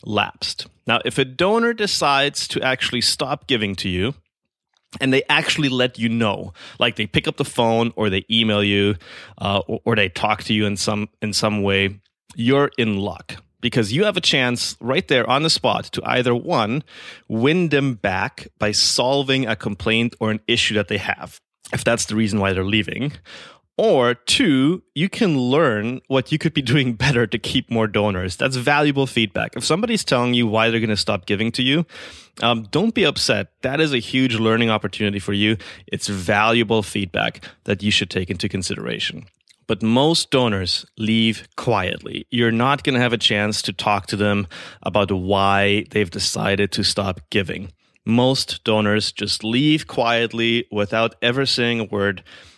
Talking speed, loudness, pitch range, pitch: 185 wpm, -19 LUFS, 105-130 Hz, 115 Hz